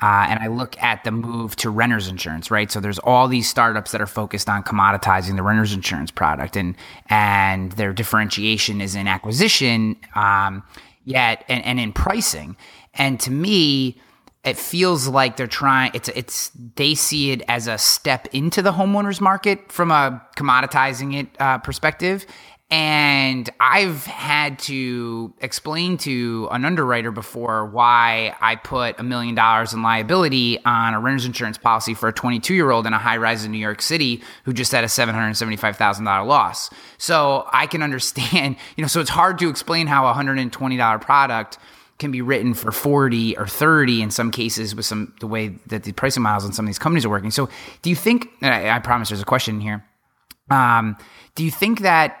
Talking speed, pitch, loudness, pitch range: 185 wpm, 120 Hz, -19 LUFS, 110-140 Hz